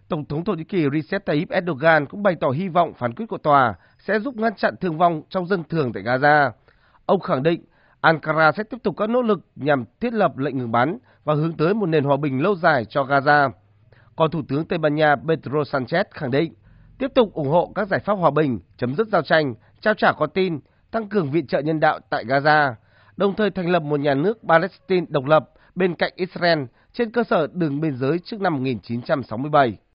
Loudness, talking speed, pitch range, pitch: -21 LUFS, 225 wpm, 140-185 Hz, 155 Hz